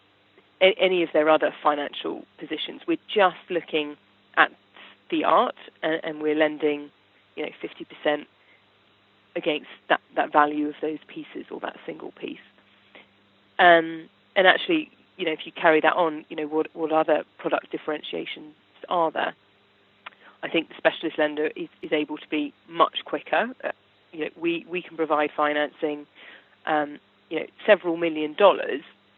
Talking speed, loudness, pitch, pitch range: 155 wpm, -24 LUFS, 155 Hz, 150-185 Hz